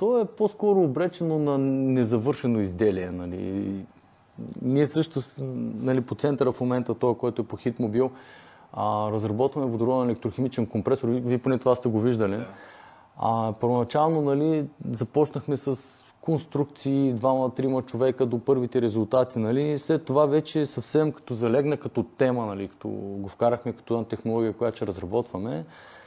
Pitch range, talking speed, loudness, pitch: 115-140 Hz, 145 wpm, -26 LUFS, 125 Hz